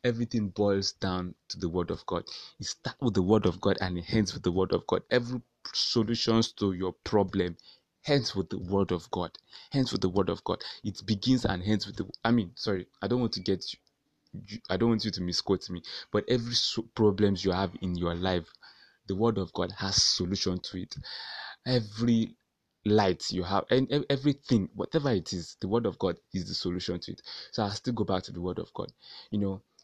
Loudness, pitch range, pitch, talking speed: -30 LUFS, 95-115 Hz, 105 Hz, 215 wpm